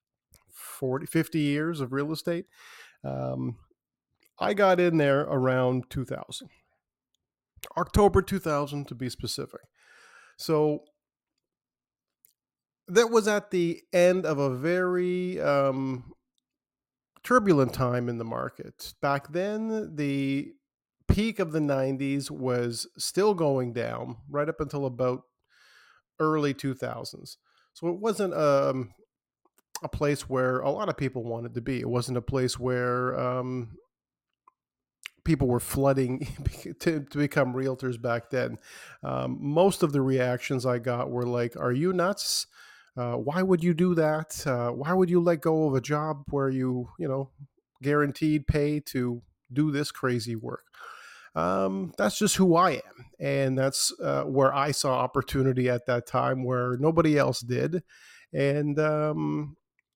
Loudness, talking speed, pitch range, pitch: -27 LUFS, 145 wpm, 125-160 Hz, 140 Hz